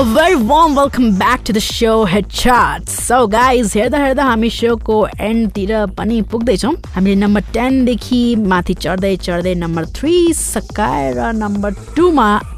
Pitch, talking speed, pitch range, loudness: 225 Hz, 155 wpm, 205-255 Hz, -14 LUFS